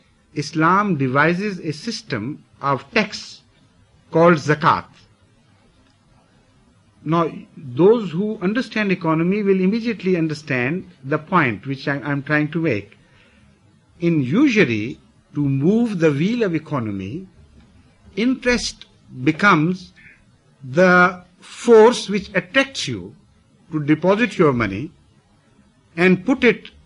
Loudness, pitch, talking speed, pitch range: -19 LUFS, 175 Hz, 105 wpm, 145-200 Hz